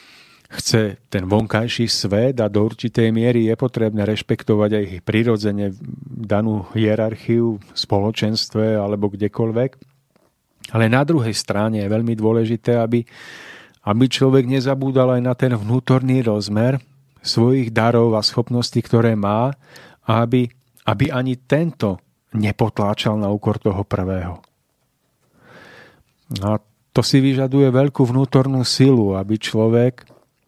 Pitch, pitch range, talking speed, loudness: 115 Hz, 105-130 Hz, 120 wpm, -18 LUFS